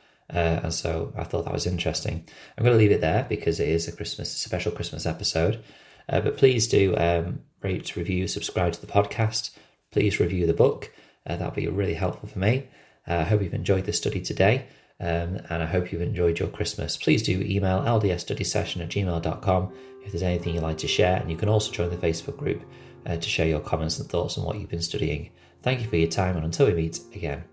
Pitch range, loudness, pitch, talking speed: 85-105 Hz, -26 LUFS, 90 Hz, 225 wpm